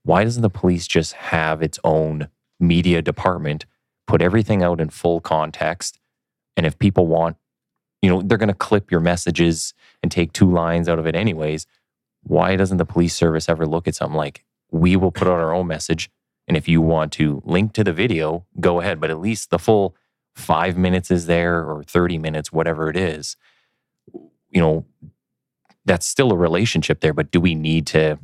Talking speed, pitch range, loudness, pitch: 195 wpm, 80-90 Hz, -19 LUFS, 85 Hz